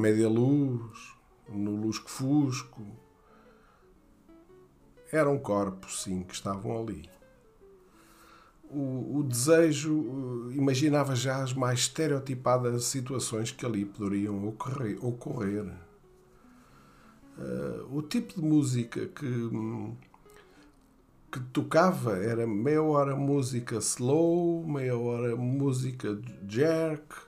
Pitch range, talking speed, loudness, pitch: 110-145 Hz, 90 wpm, -29 LUFS, 125 Hz